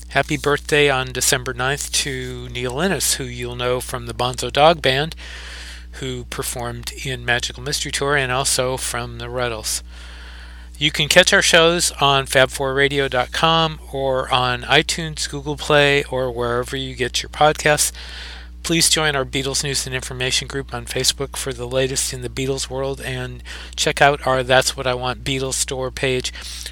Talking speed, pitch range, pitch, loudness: 165 wpm, 125-140 Hz, 130 Hz, -19 LUFS